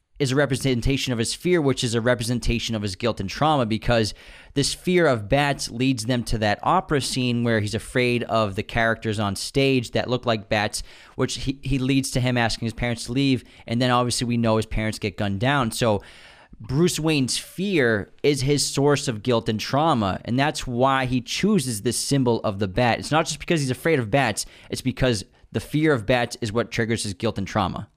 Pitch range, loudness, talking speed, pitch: 110-135 Hz, -23 LUFS, 215 wpm, 125 Hz